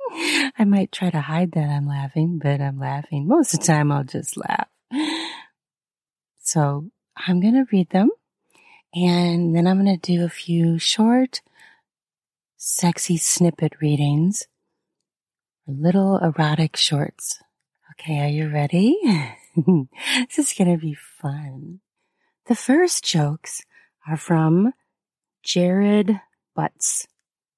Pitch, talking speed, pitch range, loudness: 175 Hz, 125 wpm, 155-210 Hz, -20 LUFS